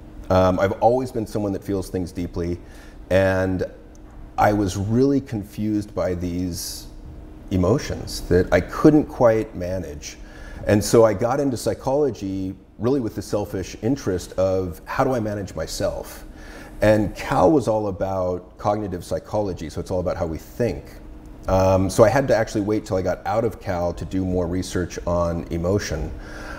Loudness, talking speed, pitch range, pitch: -22 LUFS, 165 wpm, 85-105 Hz, 95 Hz